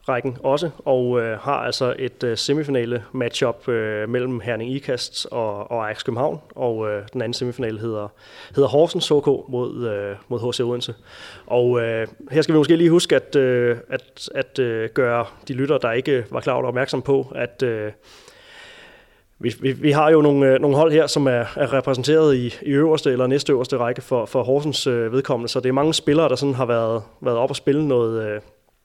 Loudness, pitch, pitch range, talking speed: -20 LUFS, 125 Hz, 120-145 Hz, 205 wpm